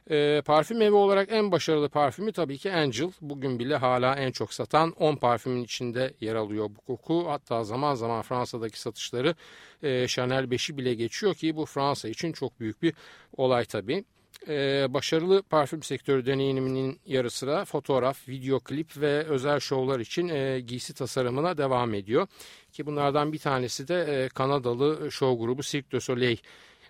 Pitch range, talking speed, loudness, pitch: 125-150 Hz, 160 wpm, -28 LUFS, 135 Hz